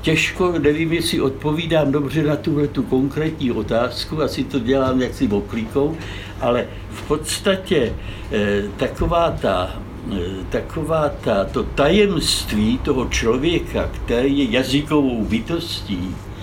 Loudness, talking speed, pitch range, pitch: -20 LUFS, 110 wpm, 105-155 Hz, 135 Hz